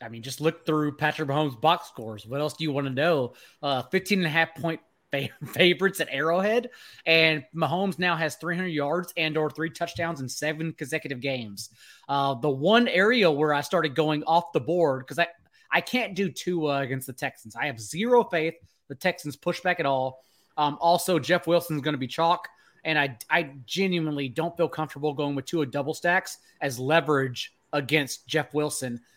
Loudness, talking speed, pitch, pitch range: -26 LUFS, 200 wpm, 155 Hz, 140-170 Hz